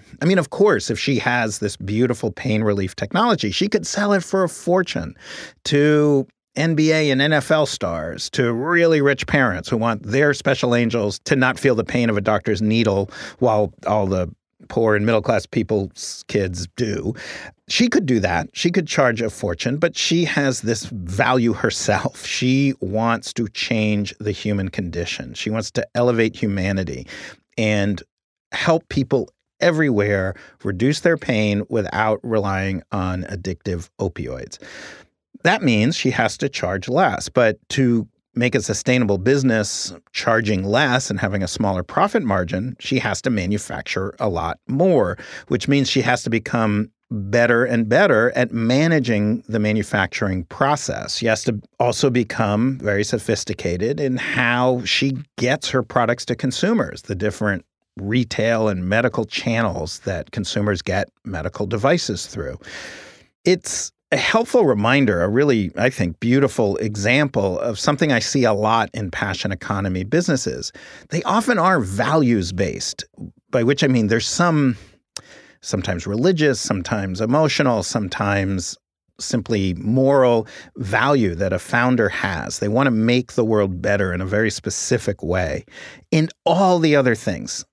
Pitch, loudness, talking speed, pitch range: 115 Hz, -20 LUFS, 150 wpm, 105-130 Hz